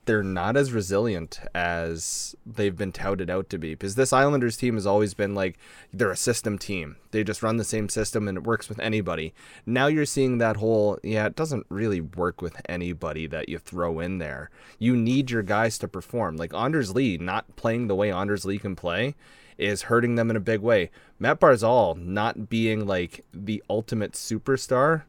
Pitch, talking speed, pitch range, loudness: 105 Hz, 200 wpm, 95-115 Hz, -26 LUFS